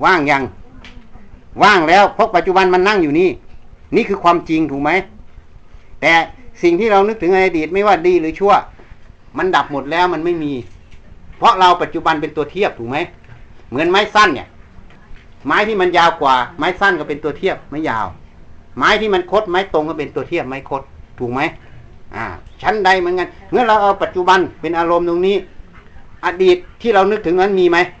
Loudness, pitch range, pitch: -15 LUFS, 145-195 Hz, 170 Hz